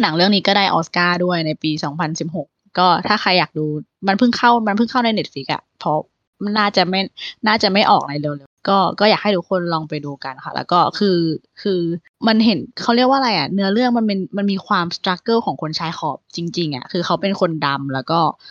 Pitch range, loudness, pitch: 160-205 Hz, -18 LUFS, 185 Hz